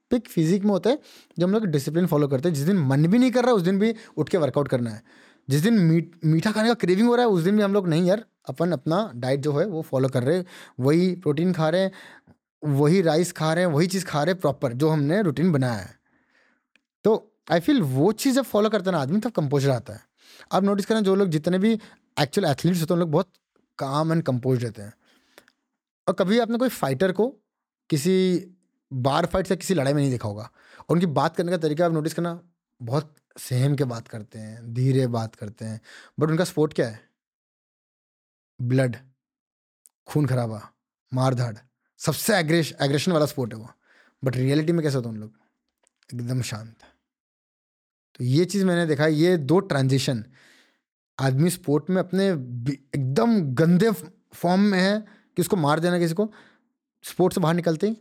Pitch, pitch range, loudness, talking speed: 165 Hz, 135-190 Hz, -23 LUFS, 200 wpm